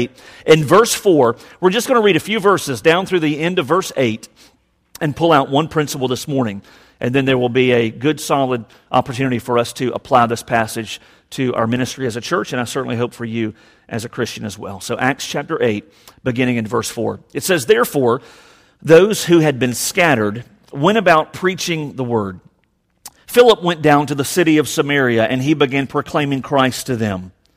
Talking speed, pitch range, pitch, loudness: 200 wpm, 120-155 Hz, 130 Hz, -16 LUFS